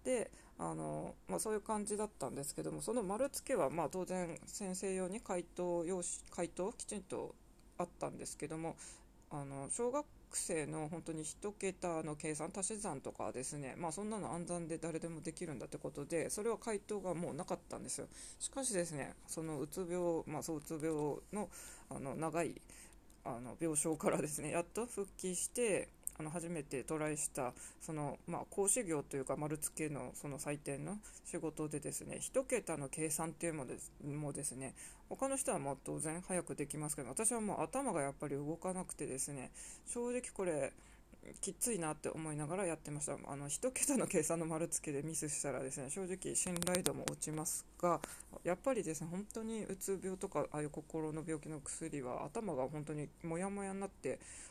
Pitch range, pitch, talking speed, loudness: 150-190 Hz, 165 Hz, 360 characters per minute, -41 LUFS